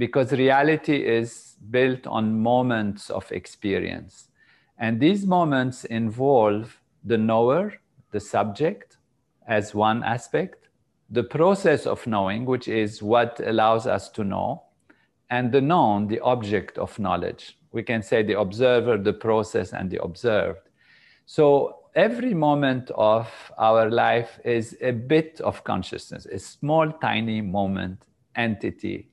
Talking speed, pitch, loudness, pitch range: 130 wpm, 115 Hz, -23 LUFS, 110-135 Hz